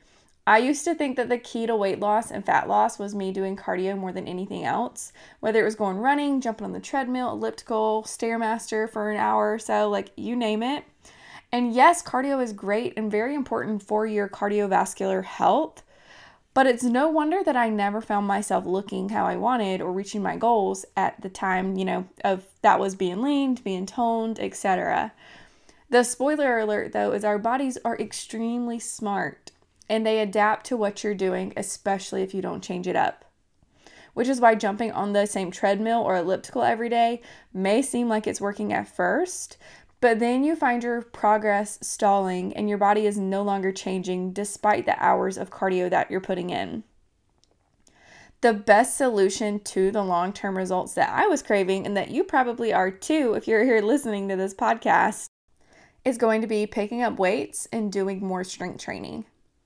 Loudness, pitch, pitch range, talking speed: -24 LUFS, 210 Hz, 195-235 Hz, 185 wpm